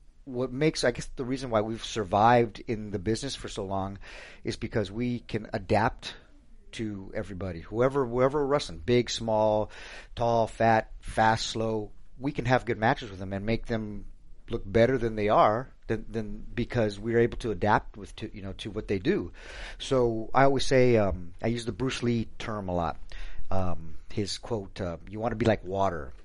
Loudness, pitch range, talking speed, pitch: -28 LUFS, 100-120 Hz, 195 wpm, 110 Hz